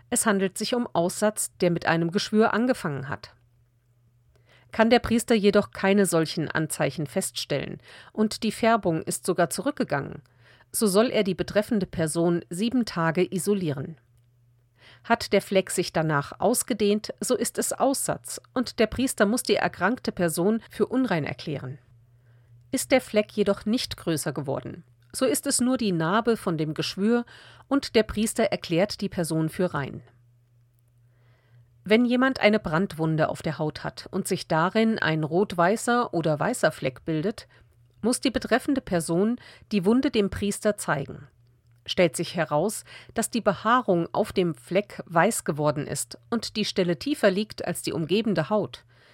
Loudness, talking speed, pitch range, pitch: -25 LUFS, 155 wpm, 150-220 Hz, 180 Hz